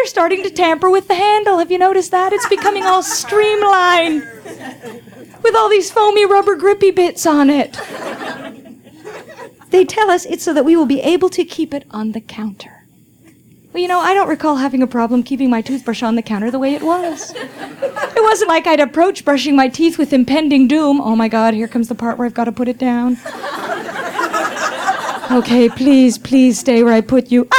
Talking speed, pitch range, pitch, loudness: 200 wpm, 245-370 Hz, 300 Hz, -14 LUFS